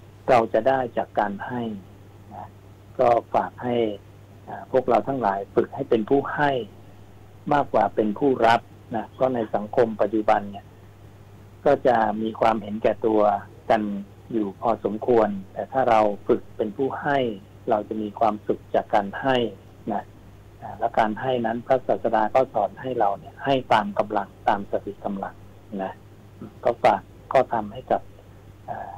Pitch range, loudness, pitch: 100-115 Hz, -24 LUFS, 105 Hz